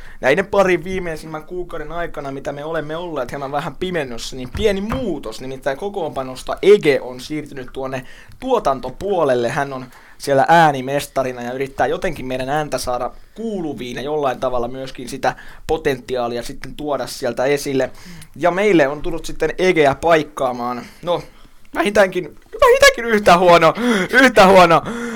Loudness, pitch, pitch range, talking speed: -17 LUFS, 150 Hz, 130-180 Hz, 135 wpm